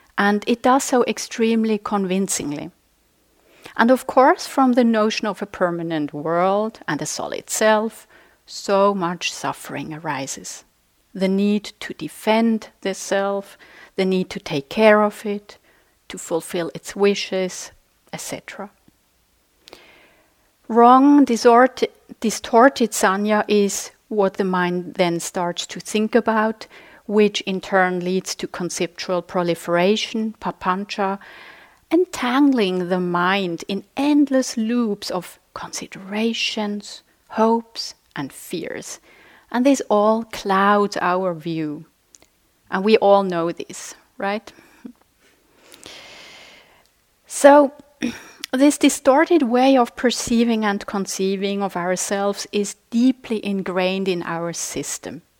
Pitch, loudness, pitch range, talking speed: 205 Hz, -20 LUFS, 185-240 Hz, 110 wpm